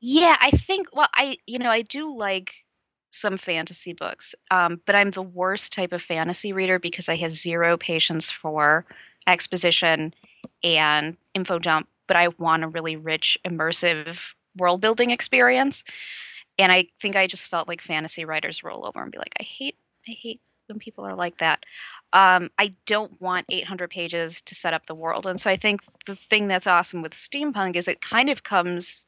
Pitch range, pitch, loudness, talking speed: 165-205 Hz, 180 Hz, -22 LUFS, 185 wpm